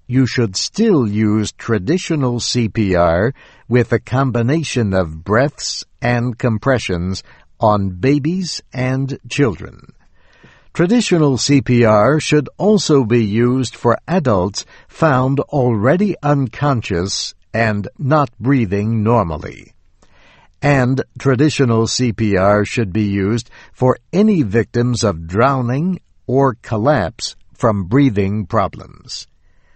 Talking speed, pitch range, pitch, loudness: 95 wpm, 105-140 Hz, 120 Hz, -16 LUFS